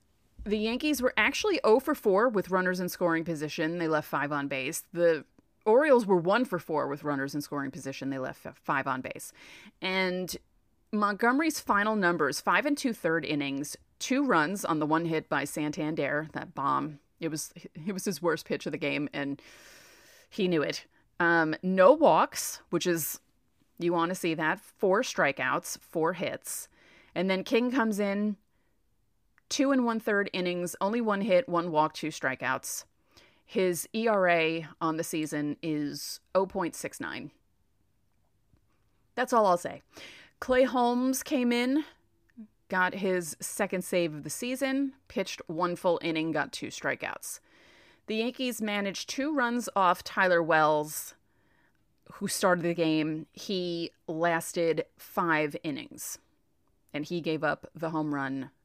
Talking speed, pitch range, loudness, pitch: 155 wpm, 155-215 Hz, -29 LUFS, 175 Hz